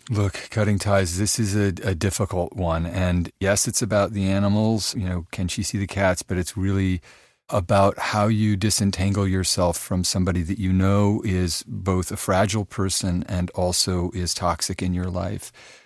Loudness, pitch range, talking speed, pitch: -23 LUFS, 90-105 Hz, 180 wpm, 95 Hz